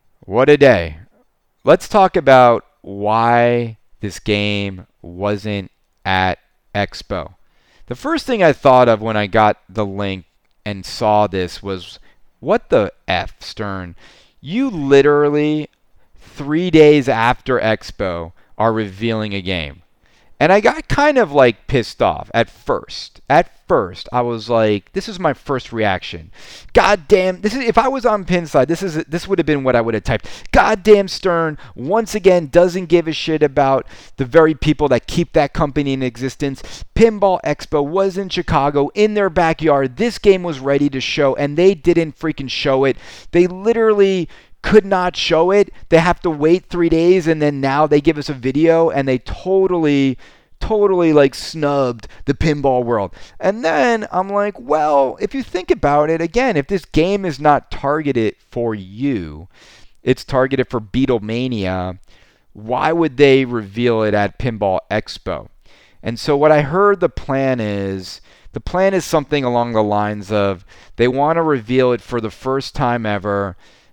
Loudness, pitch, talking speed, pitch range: -16 LUFS, 140 Hz, 165 wpm, 110-170 Hz